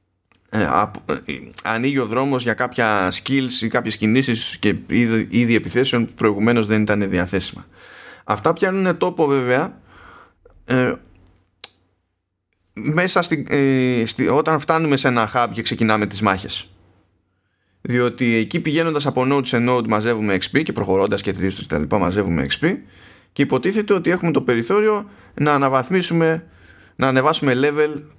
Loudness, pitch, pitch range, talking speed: -19 LUFS, 120 Hz, 100-140 Hz, 135 wpm